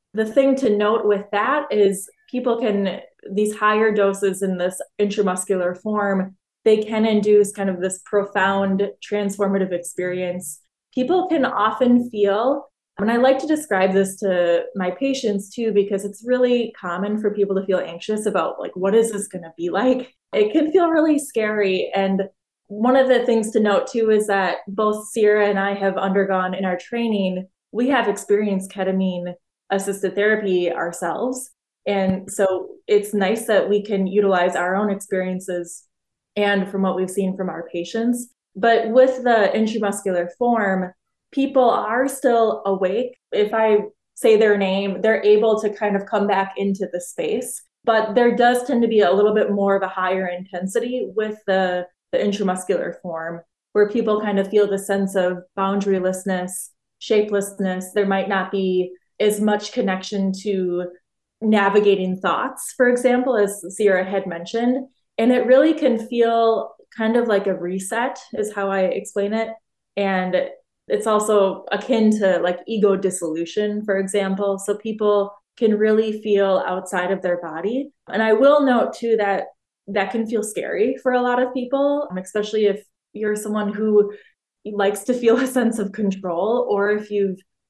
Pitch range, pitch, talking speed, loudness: 190-225 Hz, 205 Hz, 165 wpm, -20 LUFS